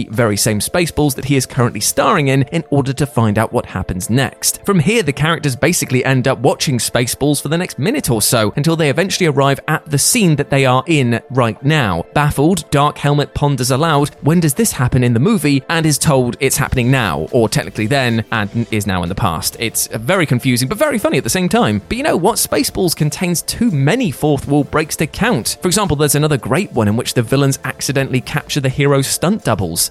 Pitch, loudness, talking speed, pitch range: 140 Hz, -15 LUFS, 225 wpm, 120-155 Hz